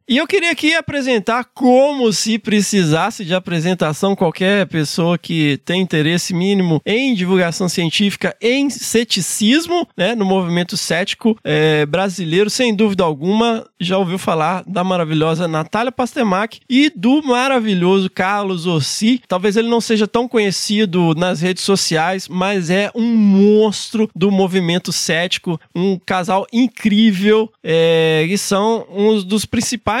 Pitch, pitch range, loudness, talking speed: 195 Hz, 180-225 Hz, -16 LUFS, 135 wpm